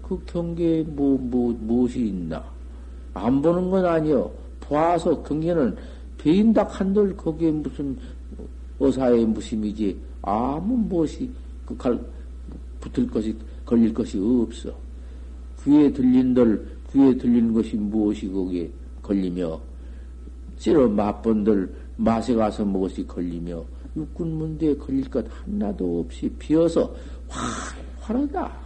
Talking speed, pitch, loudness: 235 characters per minute, 105 Hz, -23 LUFS